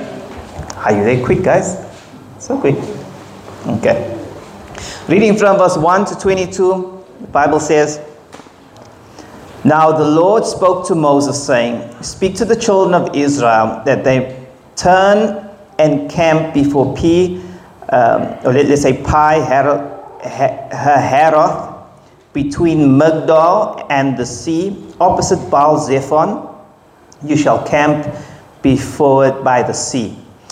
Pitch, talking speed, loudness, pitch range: 150 Hz, 120 wpm, -13 LUFS, 140-180 Hz